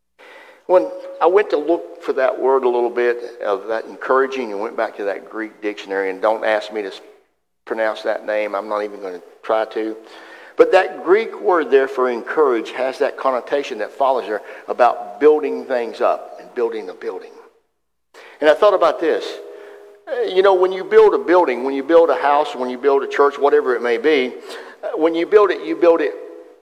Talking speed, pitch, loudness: 205 wpm, 190 Hz, -18 LUFS